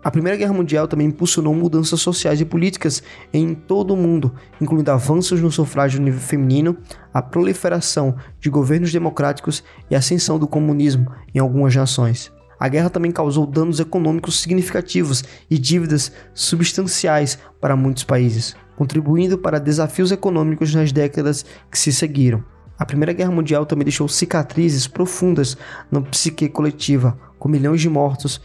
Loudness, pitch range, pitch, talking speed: -18 LUFS, 140-170 Hz, 155 Hz, 150 wpm